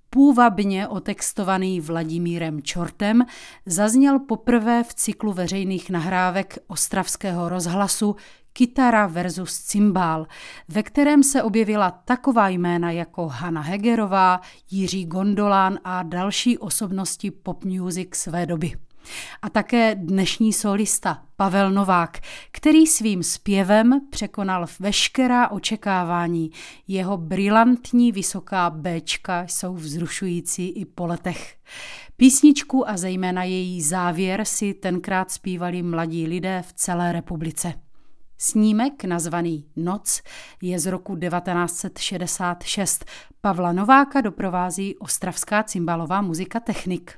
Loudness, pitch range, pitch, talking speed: -21 LUFS, 175-215 Hz, 190 Hz, 105 wpm